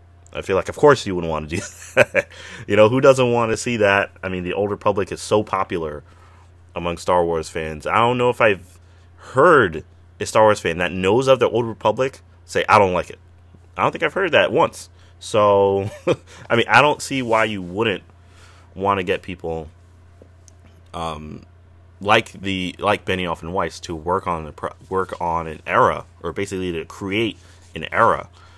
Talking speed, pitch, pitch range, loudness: 195 wpm, 90 Hz, 85-100 Hz, -19 LUFS